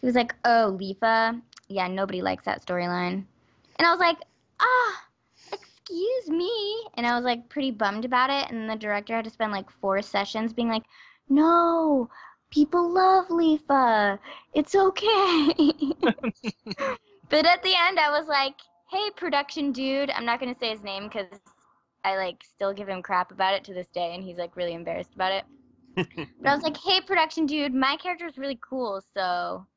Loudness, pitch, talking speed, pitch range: -25 LUFS, 250 Hz, 185 wpm, 200-315 Hz